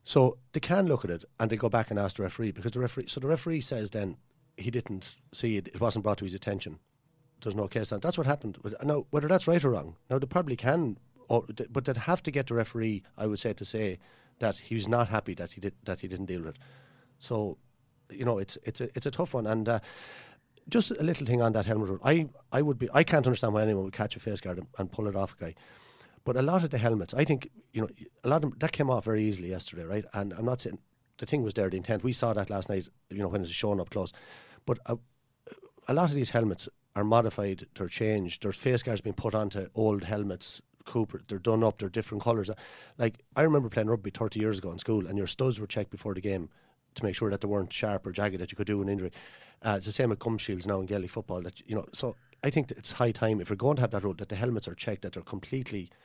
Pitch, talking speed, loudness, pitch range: 110 Hz, 270 wpm, -31 LUFS, 100-130 Hz